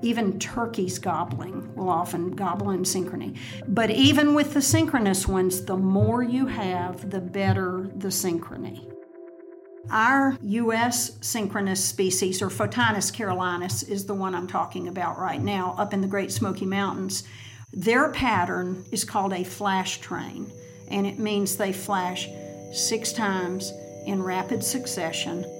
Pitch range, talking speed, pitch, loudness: 185-225 Hz, 140 wpm, 195 Hz, -25 LUFS